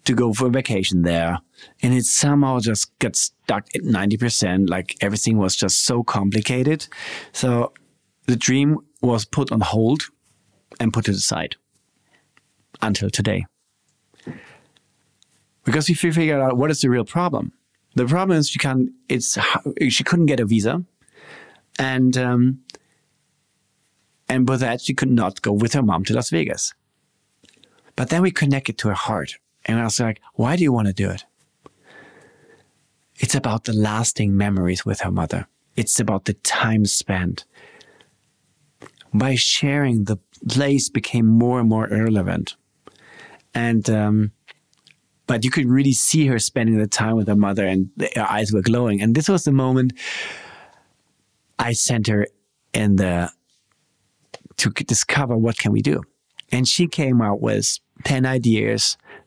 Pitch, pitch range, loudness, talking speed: 120 Hz, 105-135 Hz, -20 LUFS, 150 wpm